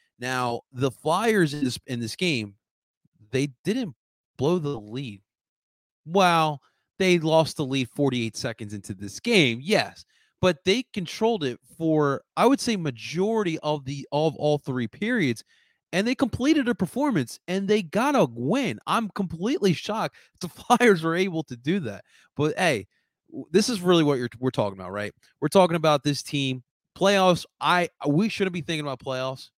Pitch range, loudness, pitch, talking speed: 130-195 Hz, -24 LUFS, 160 Hz, 170 wpm